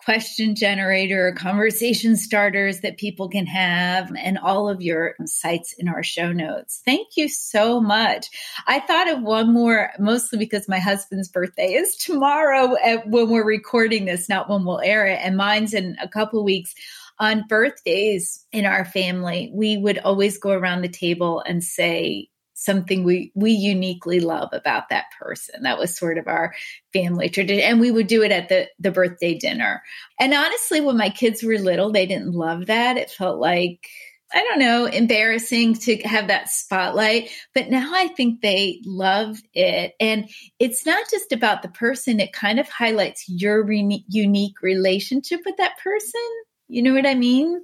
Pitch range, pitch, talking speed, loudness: 190-235 Hz, 210 Hz, 175 wpm, -20 LUFS